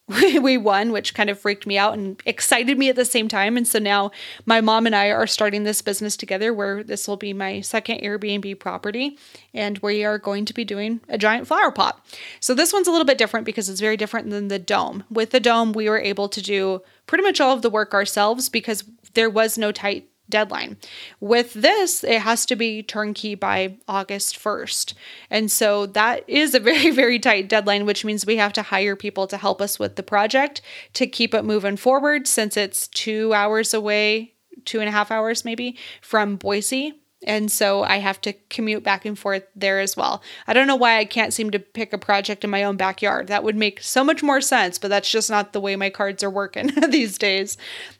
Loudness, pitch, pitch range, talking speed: -20 LUFS, 215 Hz, 200-230 Hz, 220 wpm